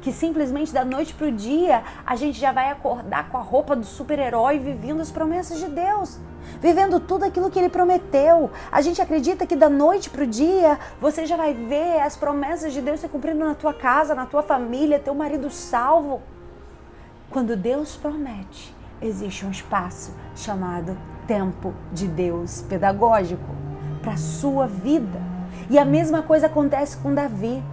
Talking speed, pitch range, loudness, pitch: 170 wpm, 235-315 Hz, -22 LUFS, 285 Hz